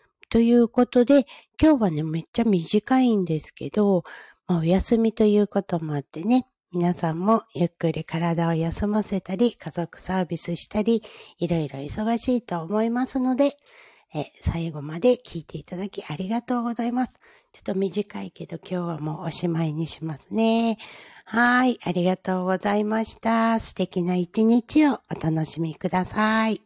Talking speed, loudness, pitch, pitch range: 325 characters per minute, -24 LUFS, 195 Hz, 170-230 Hz